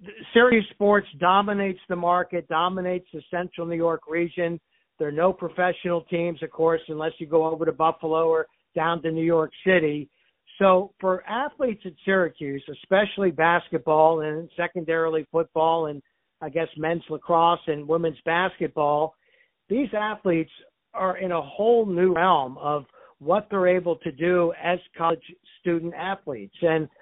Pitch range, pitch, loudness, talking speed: 160-185 Hz, 170 Hz, -24 LUFS, 150 wpm